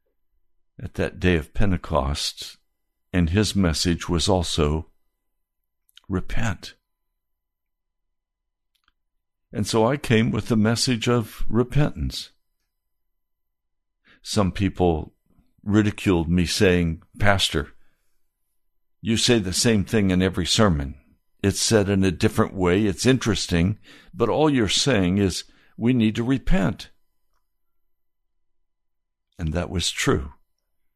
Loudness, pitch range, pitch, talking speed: -22 LUFS, 80-110 Hz, 90 Hz, 105 wpm